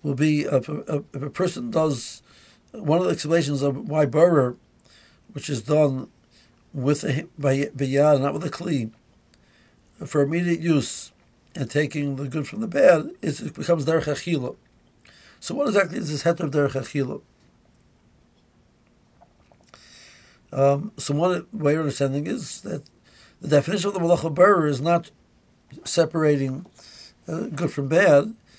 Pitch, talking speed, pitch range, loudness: 145 Hz, 145 wpm, 140-165 Hz, -23 LUFS